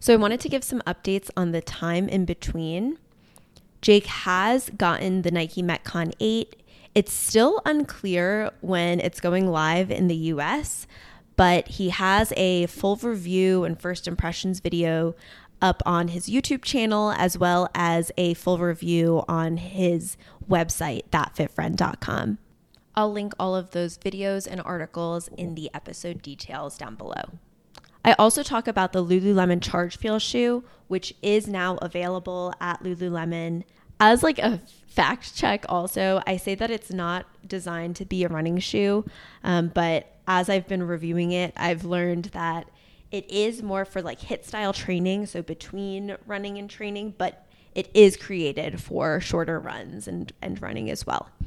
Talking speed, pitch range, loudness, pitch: 155 wpm, 170-200 Hz, -25 LUFS, 180 Hz